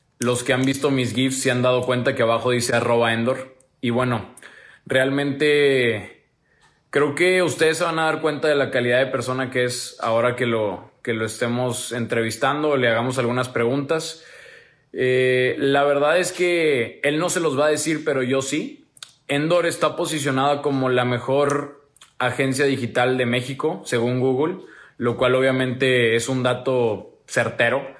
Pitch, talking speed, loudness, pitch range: 130 Hz, 165 wpm, -21 LUFS, 125-145 Hz